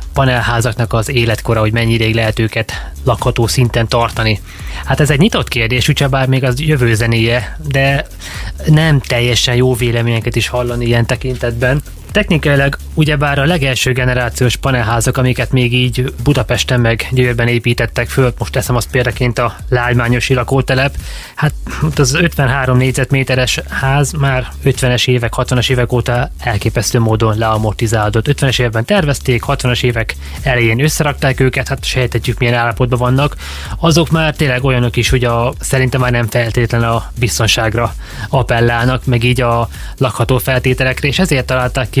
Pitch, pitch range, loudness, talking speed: 125 Hz, 115-130 Hz, -13 LUFS, 145 wpm